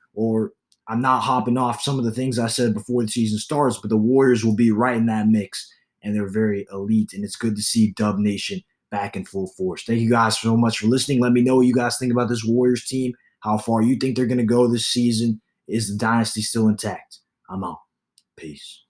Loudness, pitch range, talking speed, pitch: -21 LUFS, 110-125 Hz, 240 wpm, 115 Hz